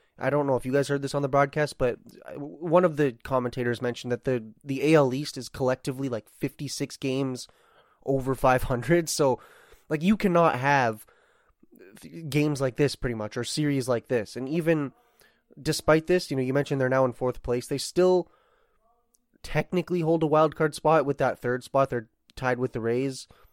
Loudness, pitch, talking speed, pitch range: -26 LUFS, 140 Hz, 185 wpm, 130-155 Hz